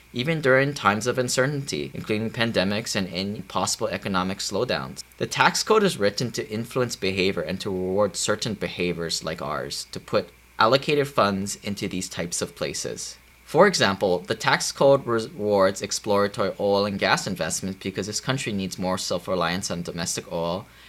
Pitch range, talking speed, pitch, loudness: 95-120 Hz, 165 wpm, 100 Hz, -24 LUFS